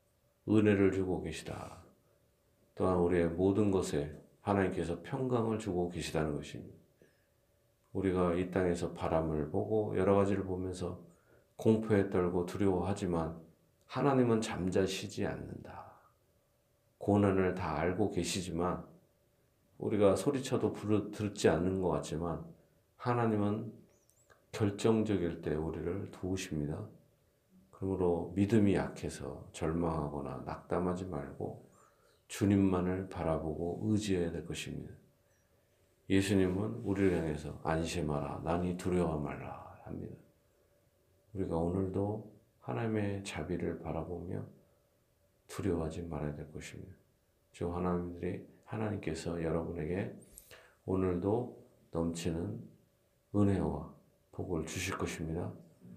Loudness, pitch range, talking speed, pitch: -34 LUFS, 85-100 Hz, 260 characters per minute, 90 Hz